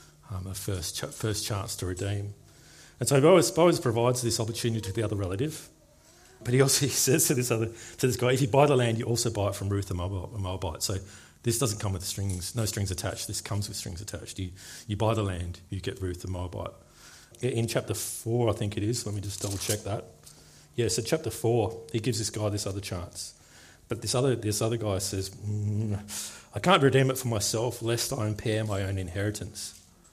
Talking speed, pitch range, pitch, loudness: 215 wpm, 100-120 Hz, 105 Hz, -28 LUFS